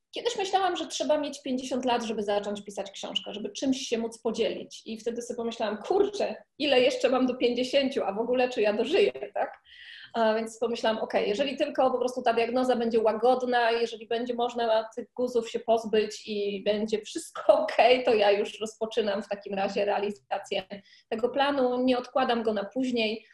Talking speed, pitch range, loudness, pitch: 185 wpm, 215-255 Hz, -28 LUFS, 235 Hz